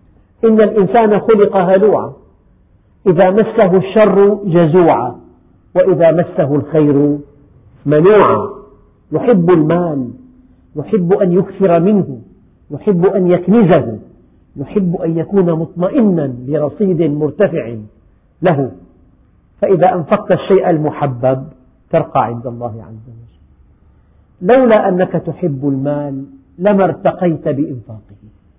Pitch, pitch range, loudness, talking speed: 165 Hz, 130-190 Hz, -13 LUFS, 90 wpm